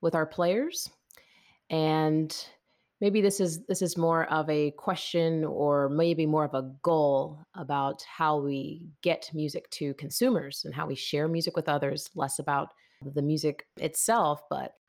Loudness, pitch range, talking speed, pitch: -29 LUFS, 145-170 Hz, 155 wpm, 155 Hz